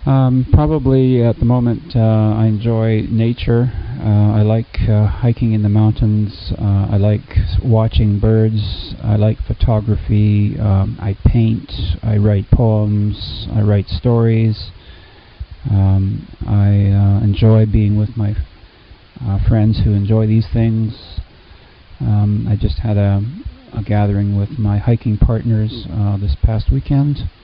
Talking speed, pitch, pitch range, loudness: 135 wpm, 105 Hz, 100-115 Hz, -15 LUFS